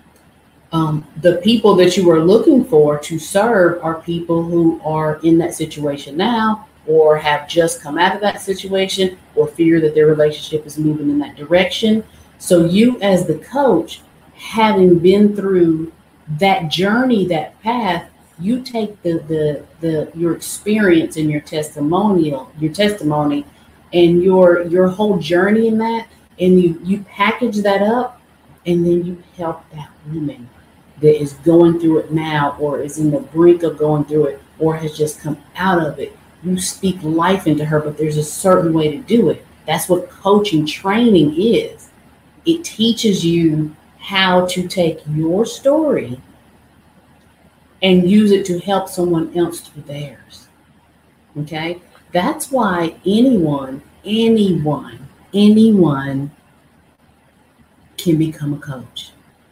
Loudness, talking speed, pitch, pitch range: -15 LUFS, 145 wpm, 170 Hz, 150-195 Hz